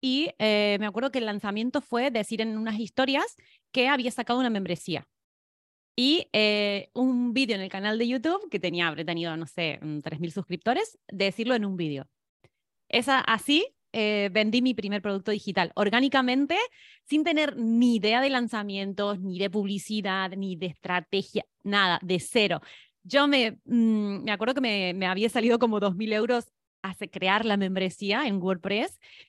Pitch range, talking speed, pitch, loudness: 195-250 Hz, 165 wpm, 215 Hz, -26 LUFS